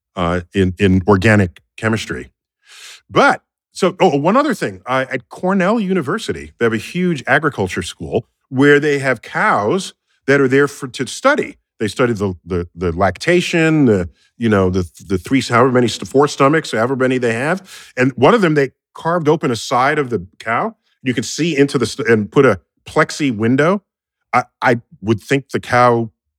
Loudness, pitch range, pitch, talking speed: -16 LUFS, 100-145 Hz, 125 Hz, 180 wpm